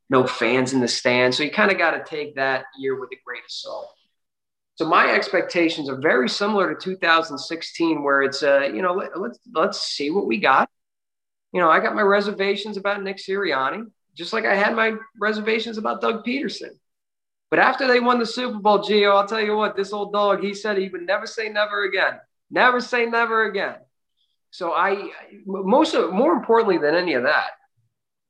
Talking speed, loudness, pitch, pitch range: 200 wpm, -21 LUFS, 200 Hz, 140-220 Hz